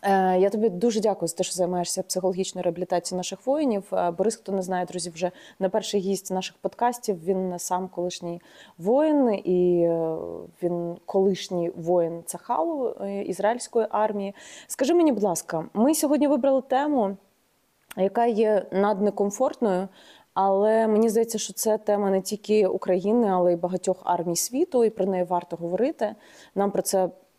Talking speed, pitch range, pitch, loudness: 145 wpm, 180-220 Hz, 195 Hz, -25 LUFS